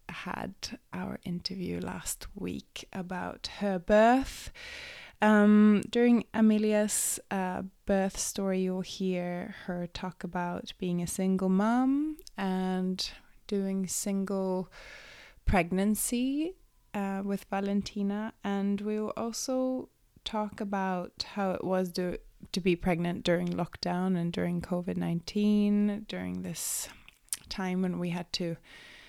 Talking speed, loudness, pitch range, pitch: 115 wpm, -30 LUFS, 180-210 Hz, 195 Hz